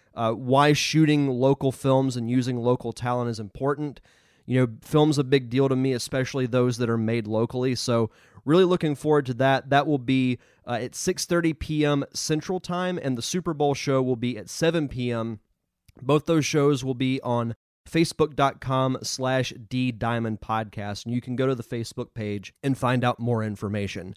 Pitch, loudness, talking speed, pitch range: 130 Hz, -25 LUFS, 180 wpm, 115-145 Hz